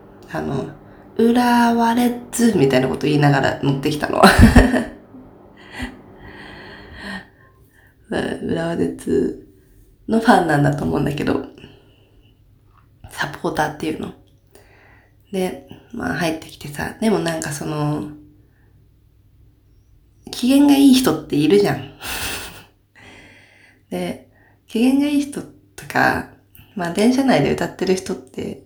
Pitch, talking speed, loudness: 130 Hz, 220 characters per minute, -18 LUFS